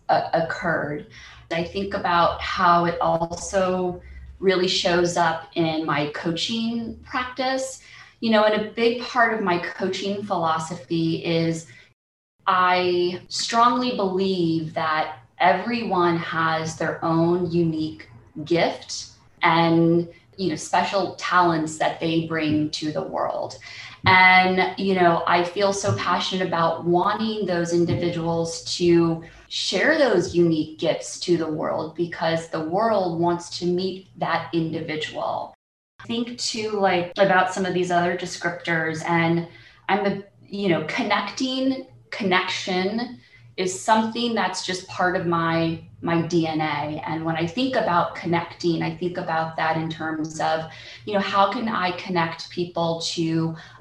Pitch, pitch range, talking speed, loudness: 170 Hz, 165-185 Hz, 135 wpm, -23 LUFS